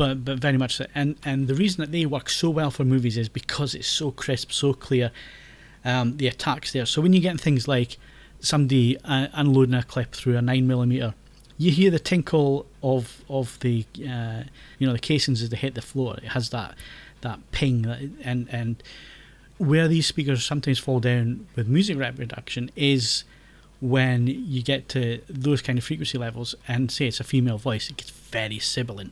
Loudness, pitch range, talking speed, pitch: -24 LUFS, 125-145 Hz, 200 wpm, 130 Hz